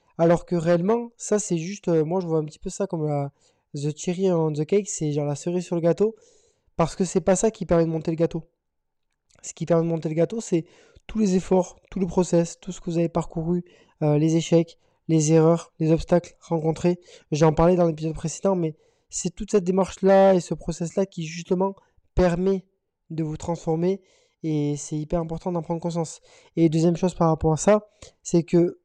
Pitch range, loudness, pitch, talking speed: 165-190 Hz, -24 LUFS, 170 Hz, 210 wpm